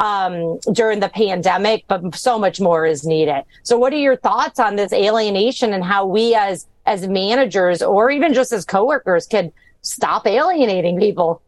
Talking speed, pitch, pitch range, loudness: 175 wpm, 200 Hz, 180-230 Hz, -17 LUFS